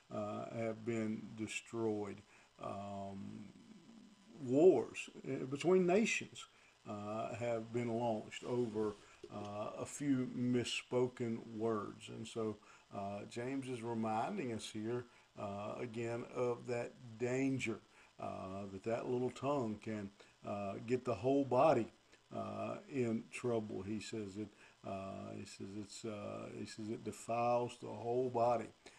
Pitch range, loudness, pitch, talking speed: 105-125 Hz, -40 LUFS, 115 Hz, 125 wpm